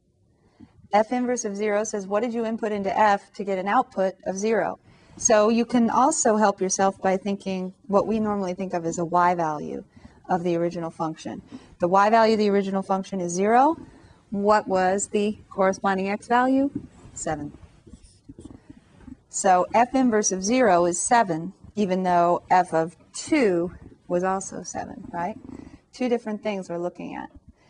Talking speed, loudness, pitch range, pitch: 165 wpm, -23 LUFS, 185-220 Hz, 200 Hz